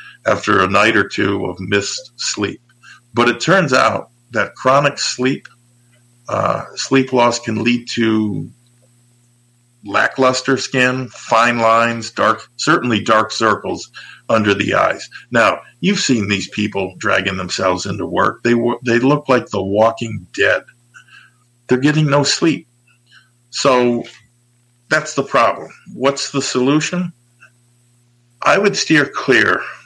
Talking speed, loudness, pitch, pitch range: 130 wpm, -16 LUFS, 120 Hz, 115-125 Hz